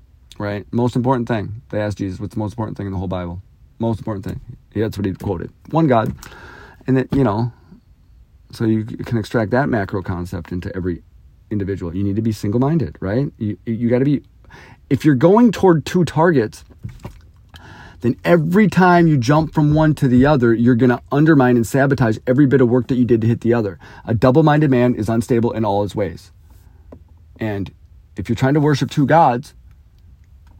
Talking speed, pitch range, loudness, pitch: 200 wpm, 95-130 Hz, -17 LUFS, 115 Hz